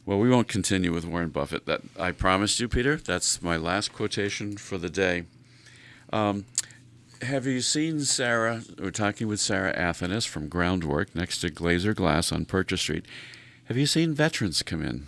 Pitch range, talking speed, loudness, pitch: 90-125 Hz, 175 wpm, -26 LUFS, 105 Hz